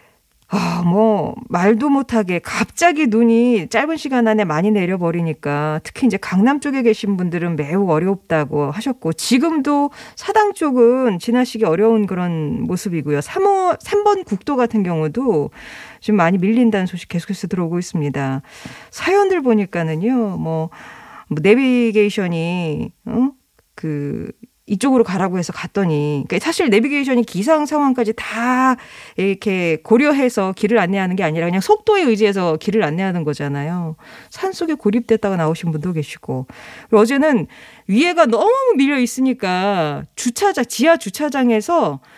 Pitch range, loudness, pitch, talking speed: 175-255 Hz, -17 LUFS, 215 Hz, 320 characters per minute